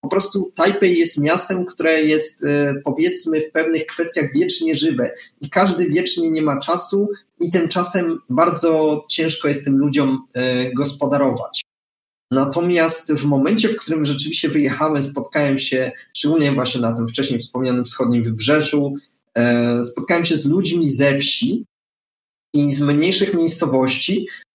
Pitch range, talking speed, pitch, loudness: 140-175 Hz, 130 wpm, 155 Hz, -18 LUFS